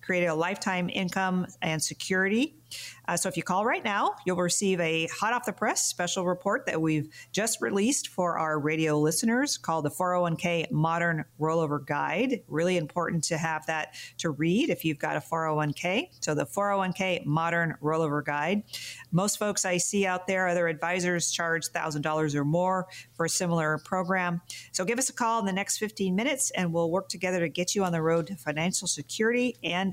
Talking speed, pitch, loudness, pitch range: 190 wpm, 175 Hz, -28 LUFS, 160-190 Hz